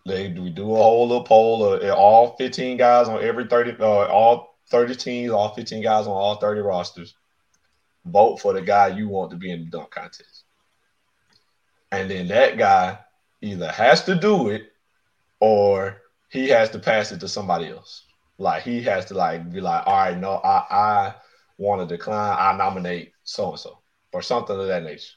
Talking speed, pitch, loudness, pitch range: 195 wpm, 110 Hz, -20 LUFS, 95-125 Hz